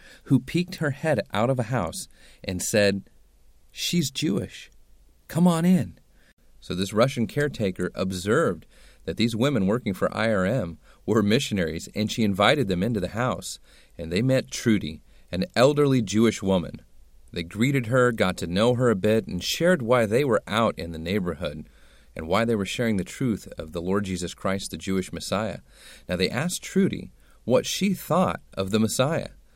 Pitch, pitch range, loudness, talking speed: 105 Hz, 90-135 Hz, -25 LUFS, 175 wpm